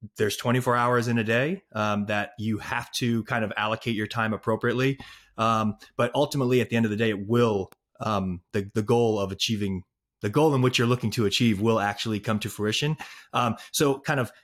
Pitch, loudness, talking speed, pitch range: 115 Hz, -26 LUFS, 215 wpm, 105-120 Hz